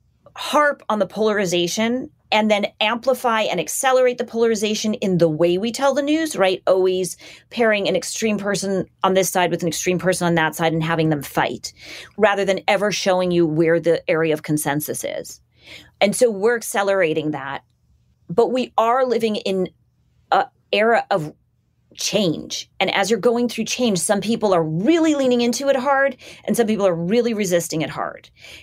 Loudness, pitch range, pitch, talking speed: -19 LUFS, 175-235 Hz, 200 Hz, 180 wpm